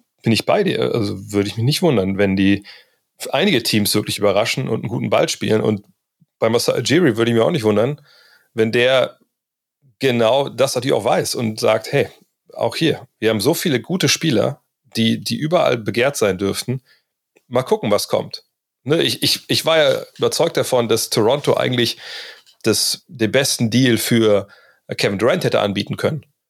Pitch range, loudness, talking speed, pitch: 105-135 Hz, -18 LUFS, 180 wpm, 115 Hz